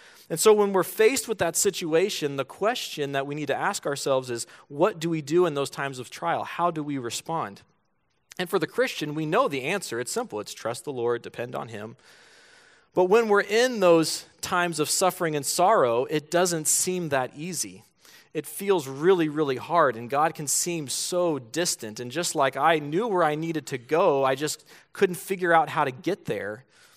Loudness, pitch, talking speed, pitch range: -25 LUFS, 165 Hz, 205 wpm, 145-180 Hz